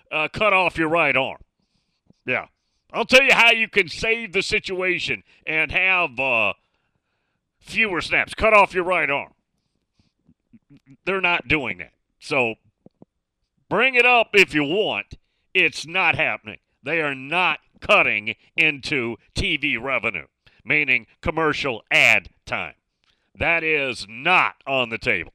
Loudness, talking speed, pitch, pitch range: -19 LUFS, 135 wpm, 160 Hz, 135-190 Hz